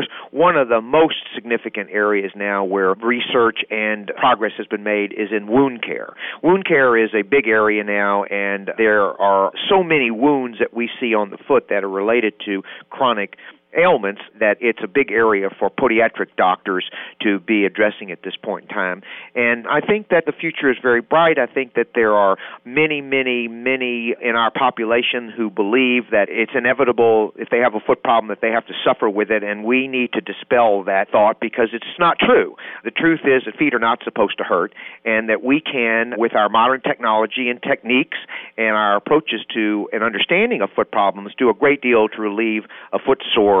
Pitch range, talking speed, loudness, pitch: 105-125 Hz, 200 wpm, -18 LUFS, 115 Hz